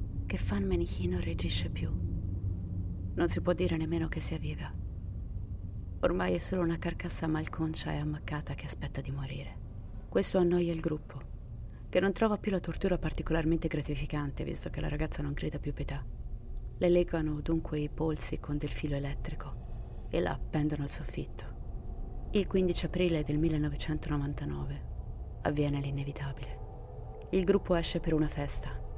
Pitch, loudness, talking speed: 140 Hz, -34 LUFS, 150 wpm